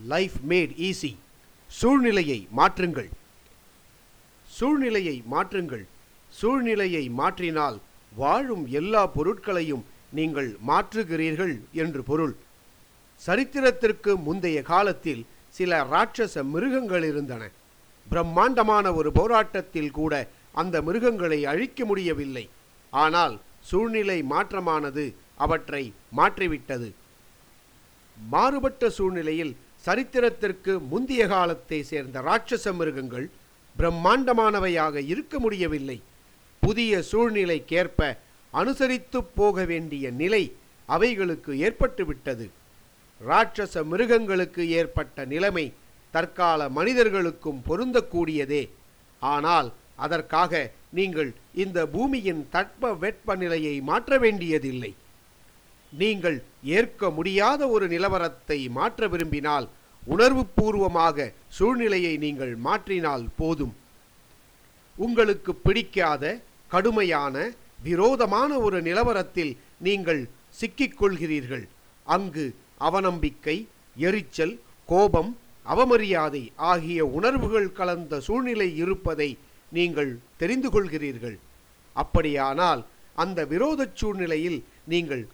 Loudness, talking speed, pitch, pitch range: -25 LUFS, 75 wpm, 170 Hz, 145-210 Hz